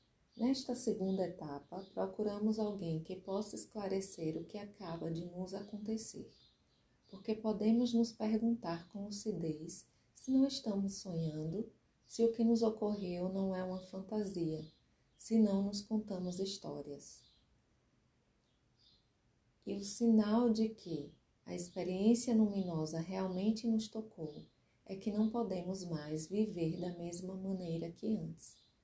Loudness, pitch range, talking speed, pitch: -38 LUFS, 170-220 Hz, 125 wpm, 195 Hz